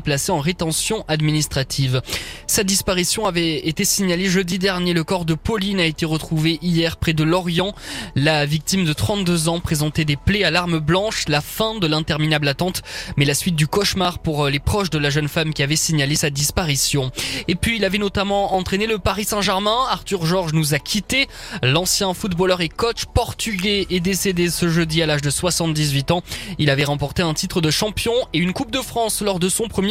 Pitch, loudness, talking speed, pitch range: 170 Hz, -19 LUFS, 200 wpm, 155-195 Hz